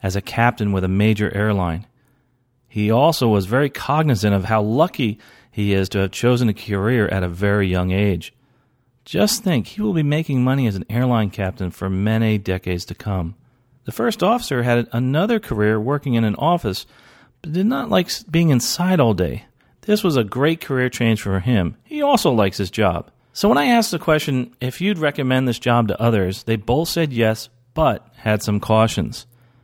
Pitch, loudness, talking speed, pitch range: 120 Hz, -19 LUFS, 190 wpm, 105-140 Hz